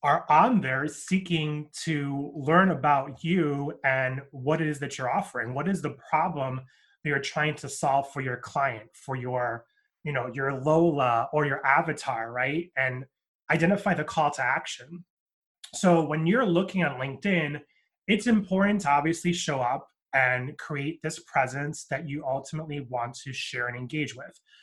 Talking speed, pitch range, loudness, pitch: 165 wpm, 135-165 Hz, -27 LUFS, 145 Hz